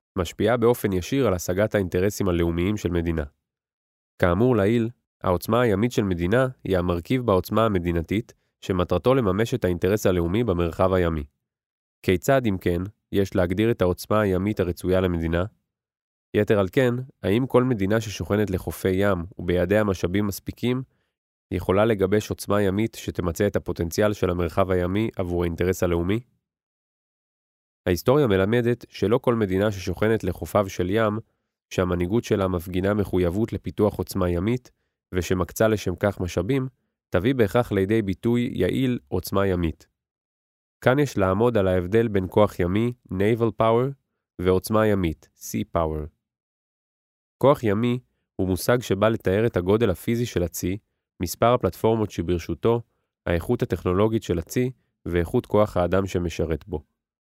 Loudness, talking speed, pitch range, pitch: -24 LUFS, 130 wpm, 90-115 Hz, 100 Hz